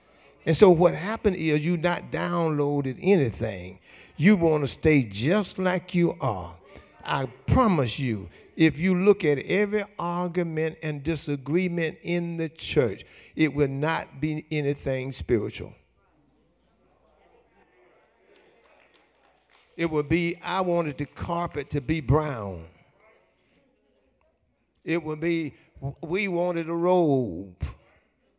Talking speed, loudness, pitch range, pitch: 115 wpm, -25 LUFS, 145-175 Hz, 160 Hz